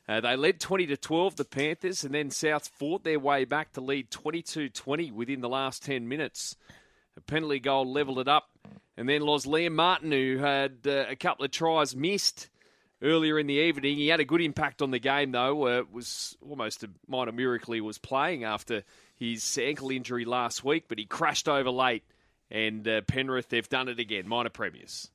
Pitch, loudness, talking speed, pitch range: 140 Hz, -29 LUFS, 205 wpm, 130-155 Hz